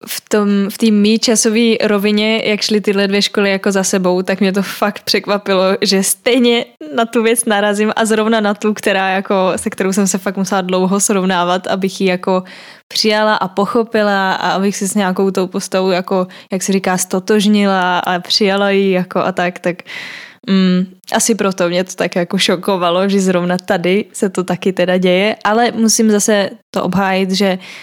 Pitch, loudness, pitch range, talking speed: 195 Hz, -14 LUFS, 190-215 Hz, 185 wpm